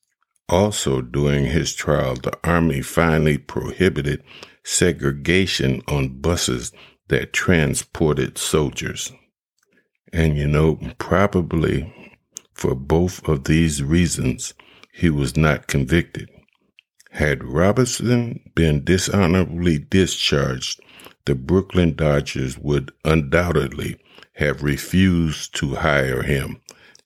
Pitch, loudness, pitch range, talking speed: 80 Hz, -20 LUFS, 70-85 Hz, 95 wpm